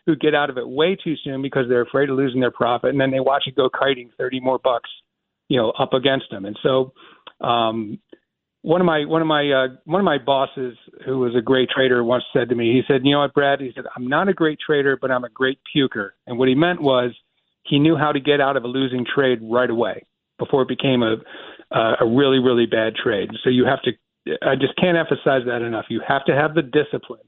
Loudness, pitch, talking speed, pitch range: -19 LUFS, 135 Hz, 250 wpm, 125-145 Hz